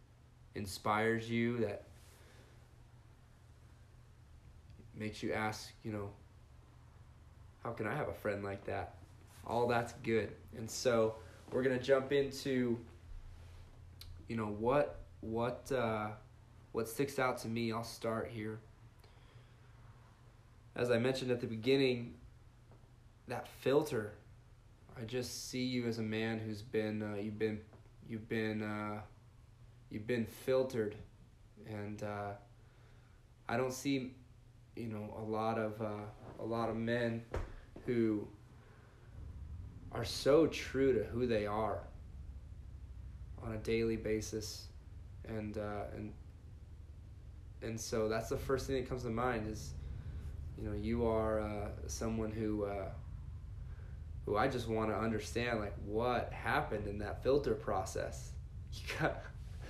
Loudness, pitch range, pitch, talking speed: -38 LUFS, 105-115 Hz, 110 Hz, 130 wpm